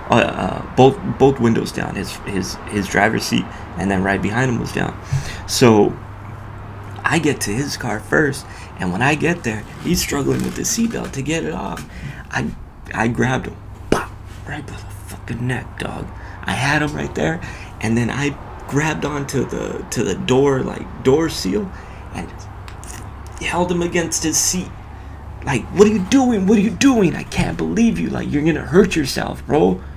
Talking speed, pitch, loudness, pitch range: 190 wpm, 105 Hz, -19 LUFS, 95-145 Hz